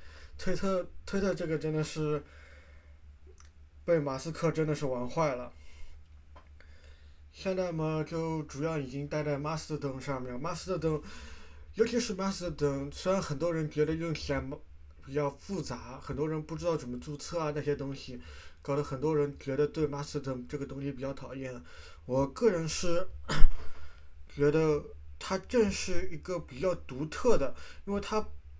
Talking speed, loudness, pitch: 230 characters per minute, -33 LUFS, 145 Hz